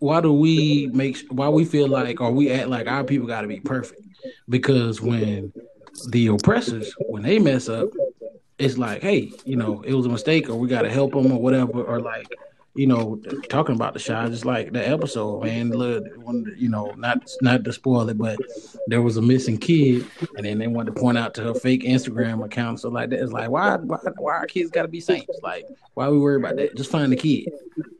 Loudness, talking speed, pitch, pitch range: -22 LUFS, 230 wpm, 130 Hz, 115-145 Hz